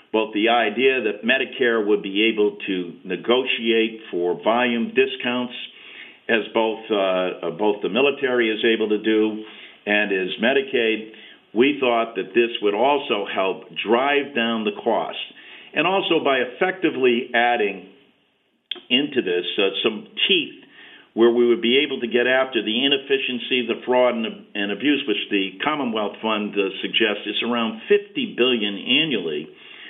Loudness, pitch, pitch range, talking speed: -21 LUFS, 120 Hz, 110-135 Hz, 145 wpm